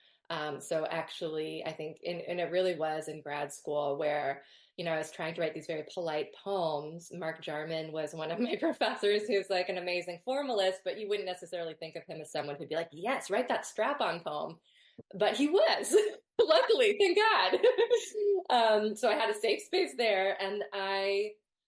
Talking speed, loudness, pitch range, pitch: 195 wpm, -32 LUFS, 160-220 Hz, 180 Hz